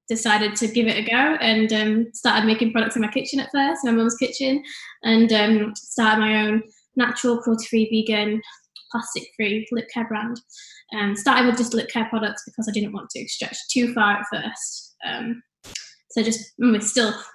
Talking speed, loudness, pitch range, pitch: 185 wpm, -21 LUFS, 215-240 Hz, 230 Hz